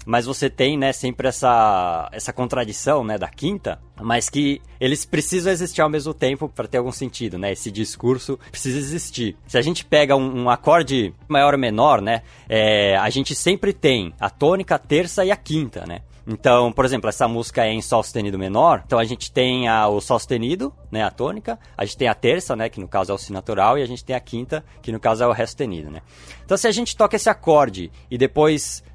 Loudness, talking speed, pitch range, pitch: -20 LUFS, 225 wpm, 110-145 Hz, 125 Hz